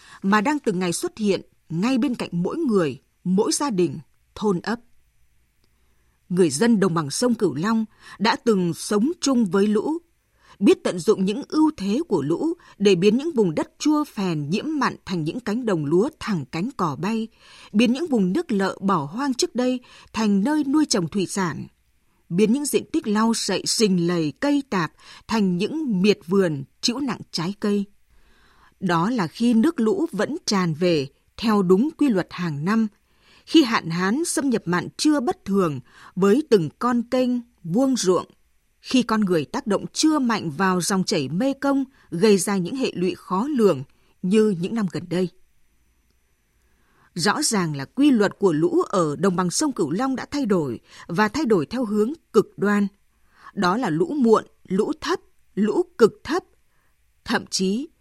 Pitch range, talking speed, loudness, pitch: 180-255 Hz, 180 wpm, -22 LUFS, 205 Hz